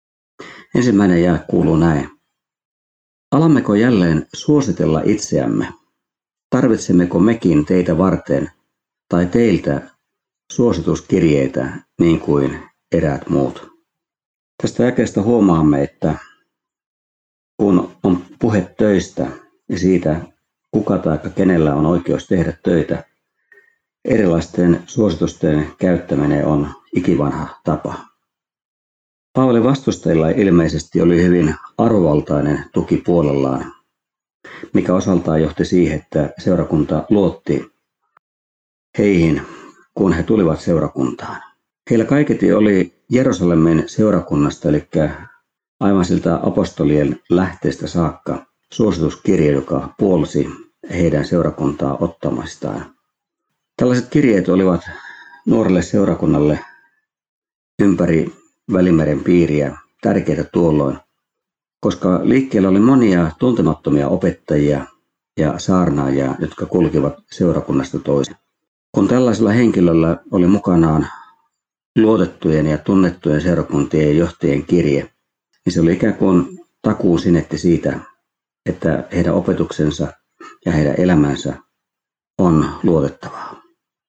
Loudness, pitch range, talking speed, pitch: -16 LUFS, 75-95 Hz, 90 wpm, 85 Hz